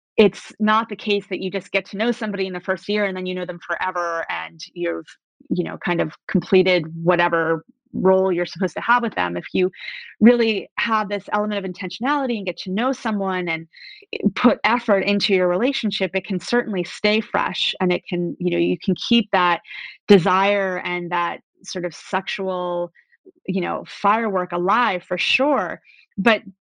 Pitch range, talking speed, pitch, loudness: 180-215 Hz, 185 wpm, 190 Hz, -21 LUFS